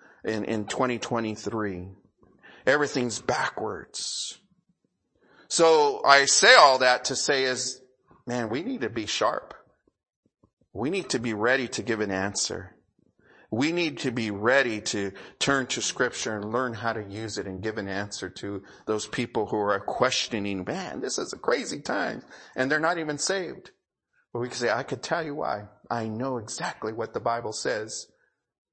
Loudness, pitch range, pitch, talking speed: -26 LUFS, 105-130 Hz, 120 Hz, 165 wpm